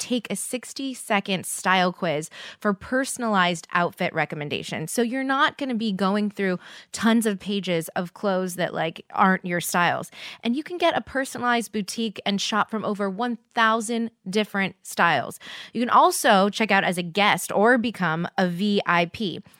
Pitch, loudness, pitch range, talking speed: 205 Hz, -23 LUFS, 185-235 Hz, 165 wpm